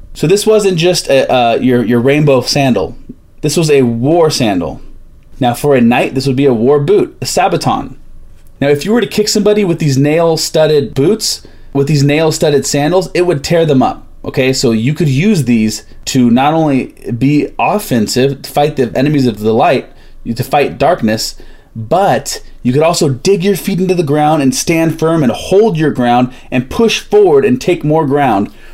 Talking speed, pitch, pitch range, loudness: 195 wpm, 145 Hz, 130-170 Hz, -11 LUFS